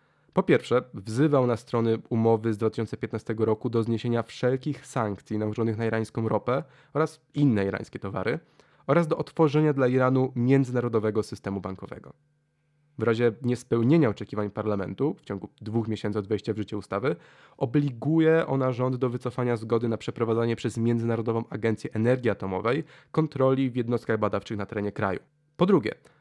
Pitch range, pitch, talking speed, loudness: 110-135 Hz, 115 Hz, 150 wpm, -27 LUFS